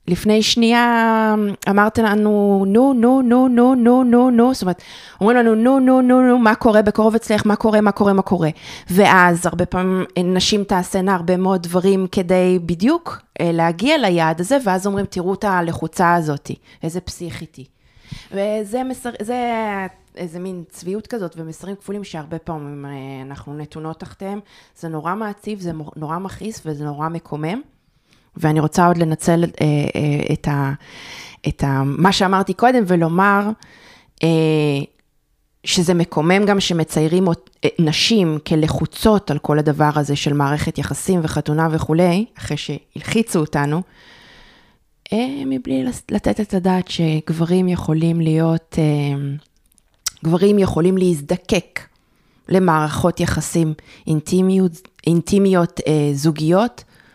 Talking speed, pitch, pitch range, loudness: 130 wpm, 180 Hz, 160-210 Hz, -17 LUFS